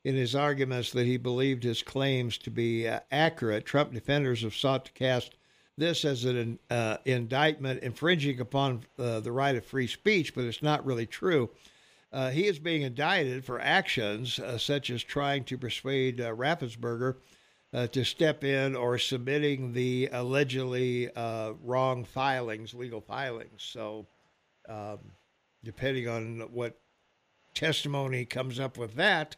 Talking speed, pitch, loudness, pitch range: 150 wpm, 130 Hz, -30 LUFS, 120-140 Hz